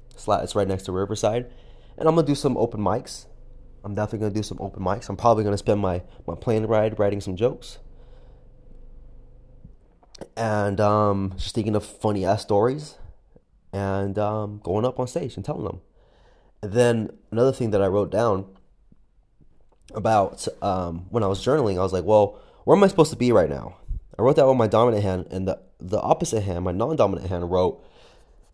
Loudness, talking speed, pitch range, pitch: -23 LUFS, 195 wpm, 95-120 Hz, 105 Hz